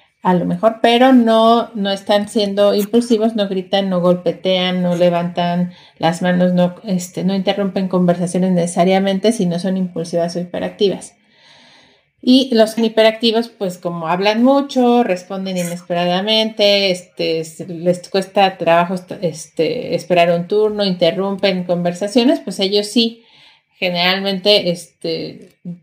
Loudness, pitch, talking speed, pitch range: -16 LUFS, 190 Hz, 125 wpm, 175-210 Hz